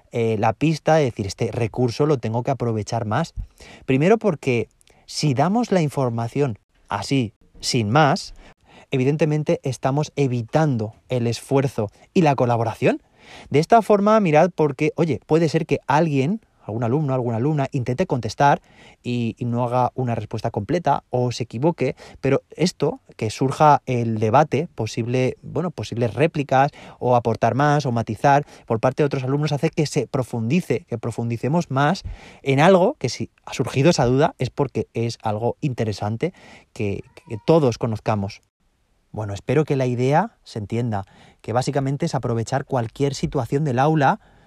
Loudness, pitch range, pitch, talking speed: -21 LUFS, 115-150 Hz, 130 Hz, 155 wpm